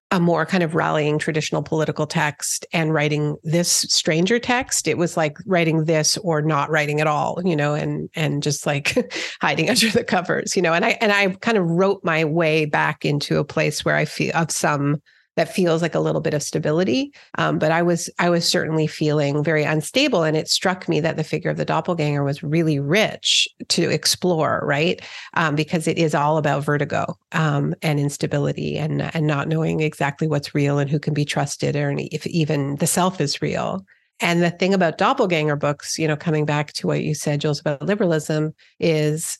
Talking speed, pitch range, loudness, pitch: 205 wpm, 150-175 Hz, -20 LUFS, 155 Hz